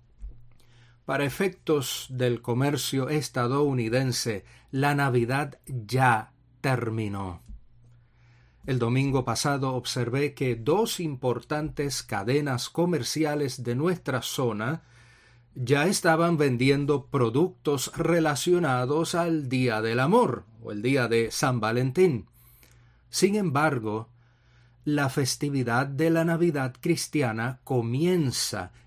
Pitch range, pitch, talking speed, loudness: 120-150 Hz, 130 Hz, 95 wpm, -26 LUFS